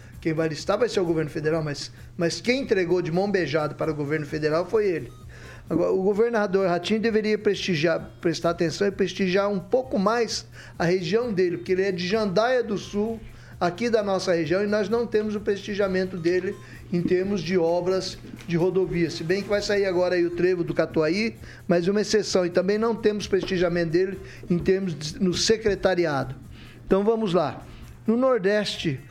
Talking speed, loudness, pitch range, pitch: 185 wpm, -24 LUFS, 170-210 Hz, 185 Hz